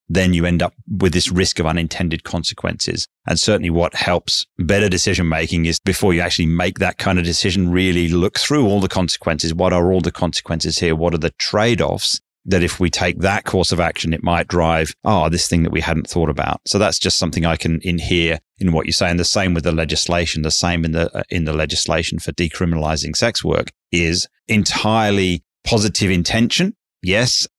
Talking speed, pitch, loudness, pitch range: 210 wpm, 85 Hz, -17 LUFS, 80-95 Hz